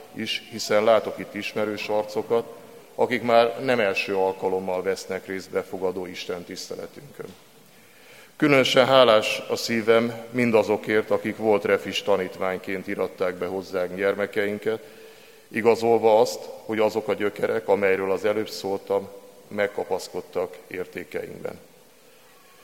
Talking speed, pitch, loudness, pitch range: 110 wpm, 115 Hz, -24 LUFS, 100-150 Hz